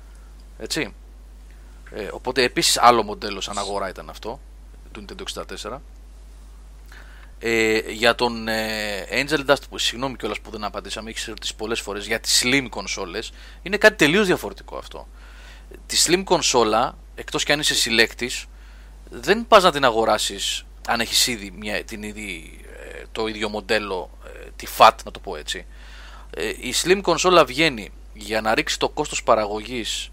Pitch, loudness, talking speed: 110 Hz, -20 LUFS, 155 wpm